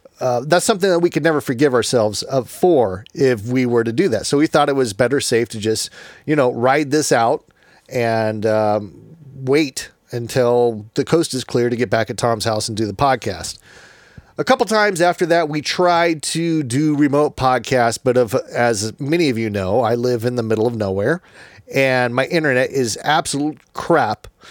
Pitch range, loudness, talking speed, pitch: 115-150 Hz, -18 LUFS, 195 wpm, 130 Hz